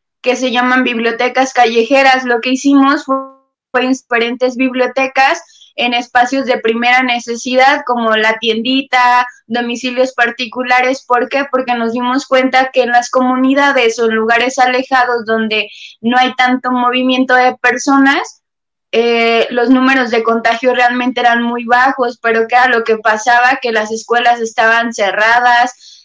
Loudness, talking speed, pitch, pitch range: -12 LUFS, 145 wpm, 245 Hz, 235-255 Hz